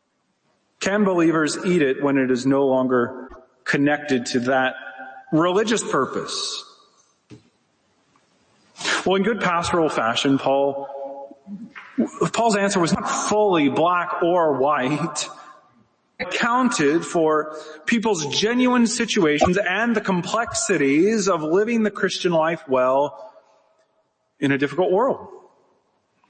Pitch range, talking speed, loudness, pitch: 140-210 Hz, 110 wpm, -20 LUFS, 170 Hz